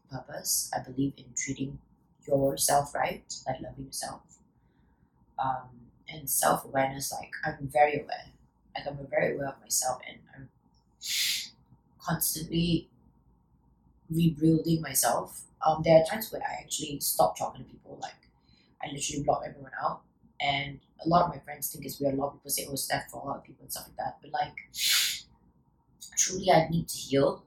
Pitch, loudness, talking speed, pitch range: 140 Hz, -29 LUFS, 175 wpm, 135-160 Hz